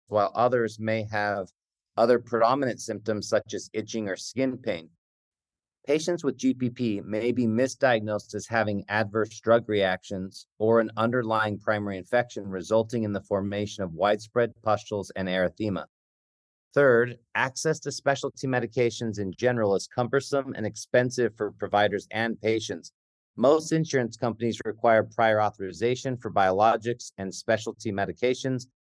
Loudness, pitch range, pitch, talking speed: -27 LUFS, 105-125 Hz, 110 Hz, 135 wpm